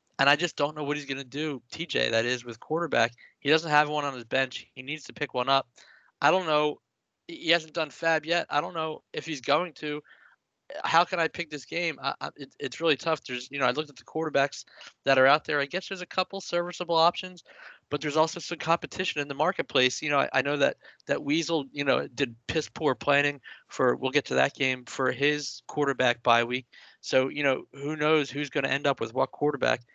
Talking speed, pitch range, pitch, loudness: 240 wpm, 135-165 Hz, 150 Hz, -27 LUFS